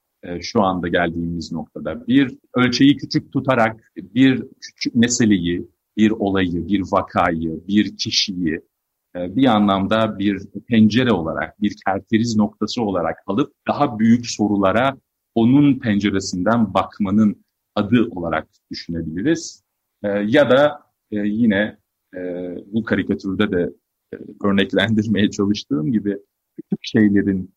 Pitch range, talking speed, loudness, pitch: 95-115 Hz, 100 wpm, -19 LUFS, 105 Hz